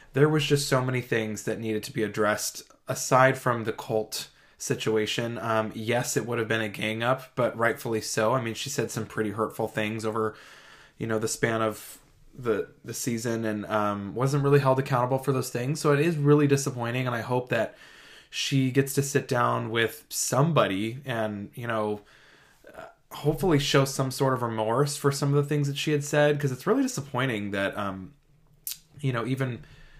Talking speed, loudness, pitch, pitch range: 195 wpm, -27 LUFS, 125 Hz, 110-140 Hz